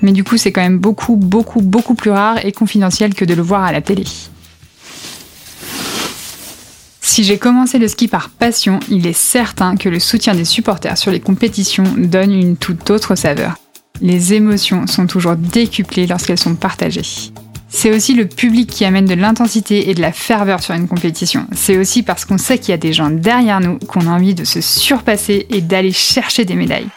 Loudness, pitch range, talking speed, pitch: -13 LUFS, 180-220 Hz, 200 wpm, 195 Hz